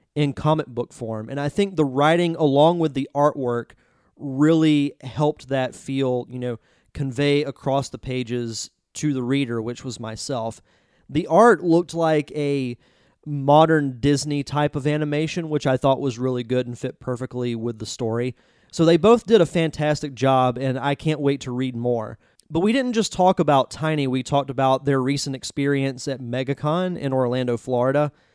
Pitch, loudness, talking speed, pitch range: 140 Hz, -22 LUFS, 175 wpm, 125-150 Hz